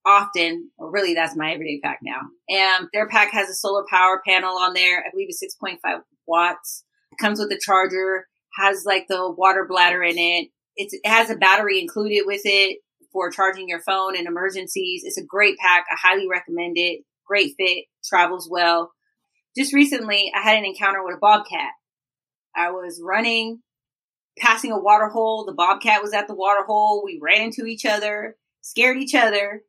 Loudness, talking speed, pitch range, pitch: -19 LUFS, 185 wpm, 185-220 Hz, 200 Hz